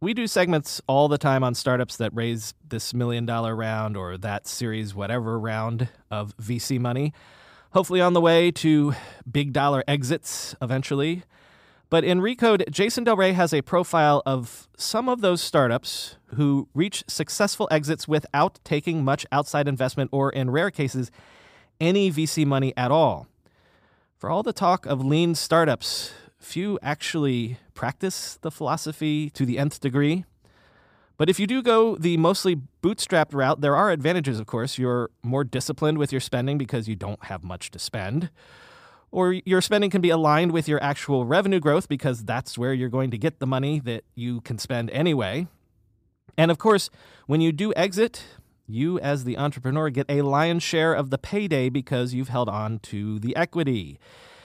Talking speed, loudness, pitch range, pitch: 170 wpm, -24 LUFS, 125-165 Hz, 145 Hz